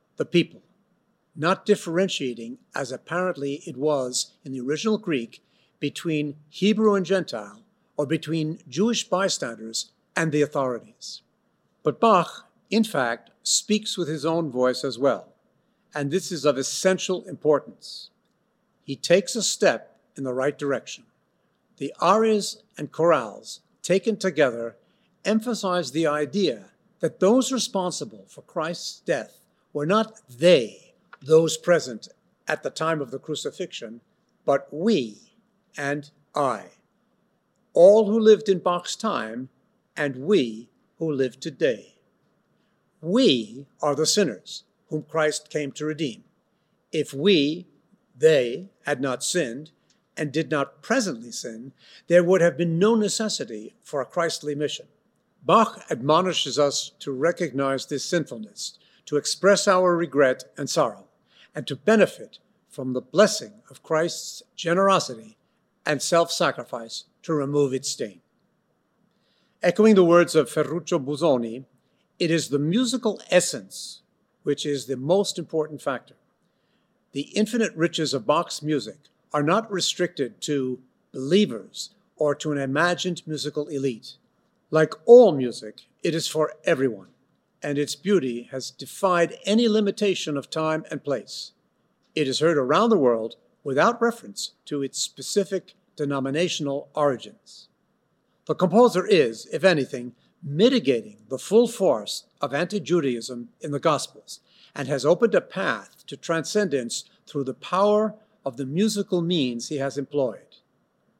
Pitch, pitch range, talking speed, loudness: 160 Hz, 140-195 Hz, 130 wpm, -24 LUFS